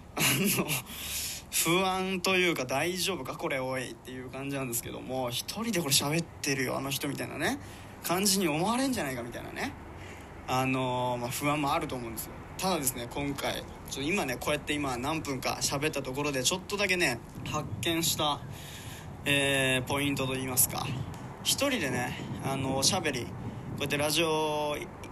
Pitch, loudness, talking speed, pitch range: 140 Hz, -30 LUFS, 350 characters per minute, 130-160 Hz